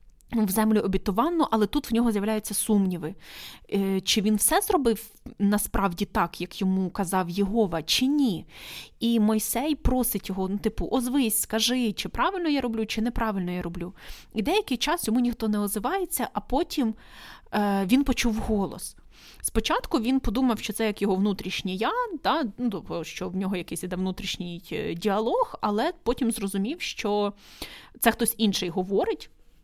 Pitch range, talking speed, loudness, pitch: 195-245 Hz, 150 wpm, -26 LUFS, 215 Hz